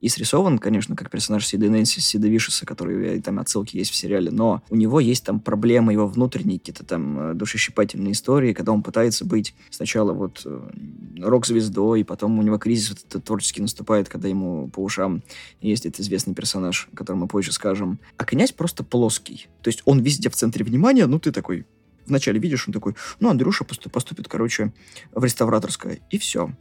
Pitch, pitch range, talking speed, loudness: 110 Hz, 100-120 Hz, 180 wpm, -22 LUFS